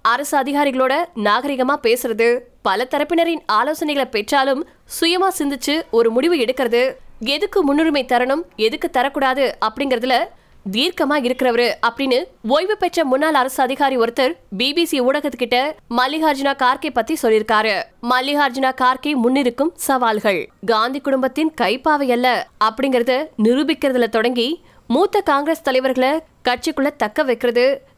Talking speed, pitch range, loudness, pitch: 110 wpm, 245-305 Hz, -18 LUFS, 270 Hz